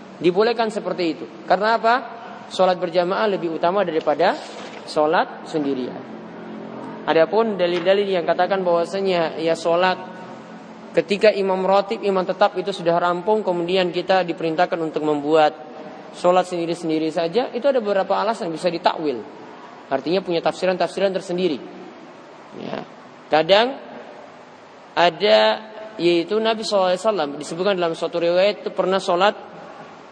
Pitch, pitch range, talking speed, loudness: 185 Hz, 170-205 Hz, 115 wpm, -20 LUFS